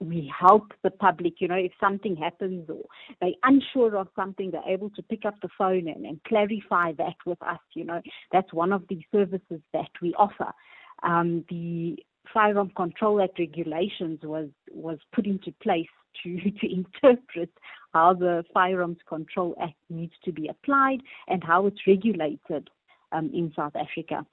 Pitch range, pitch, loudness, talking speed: 170-200 Hz, 180 Hz, -26 LUFS, 165 wpm